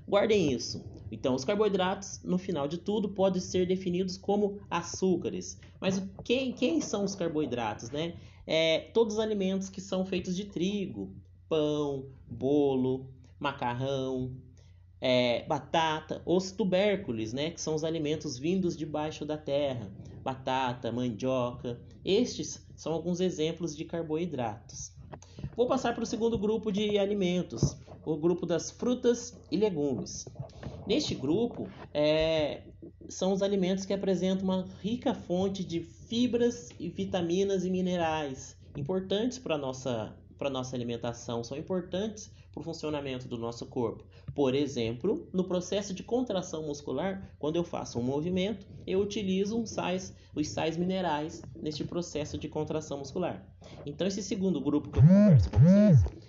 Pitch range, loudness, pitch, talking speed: 135-190 Hz, -31 LUFS, 160 Hz, 140 wpm